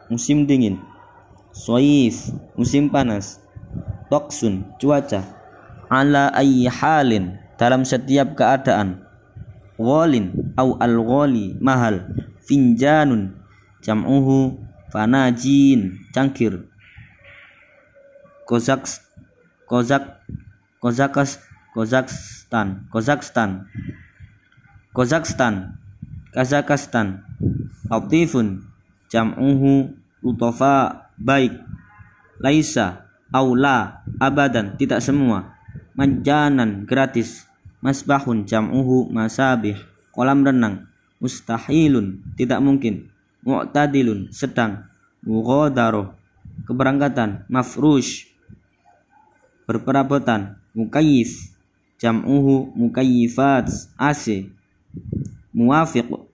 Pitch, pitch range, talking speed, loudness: 120 Hz, 105-135 Hz, 65 wpm, -19 LUFS